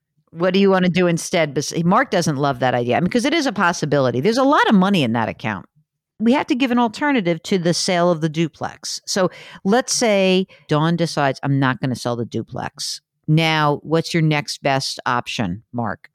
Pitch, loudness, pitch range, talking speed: 165 Hz, -19 LUFS, 145-190 Hz, 215 wpm